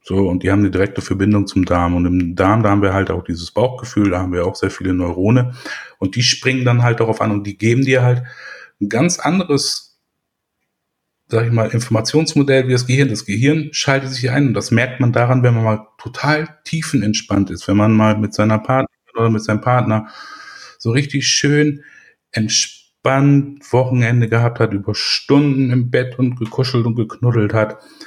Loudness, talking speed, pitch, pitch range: -16 LUFS, 190 wpm, 115 Hz, 100-130 Hz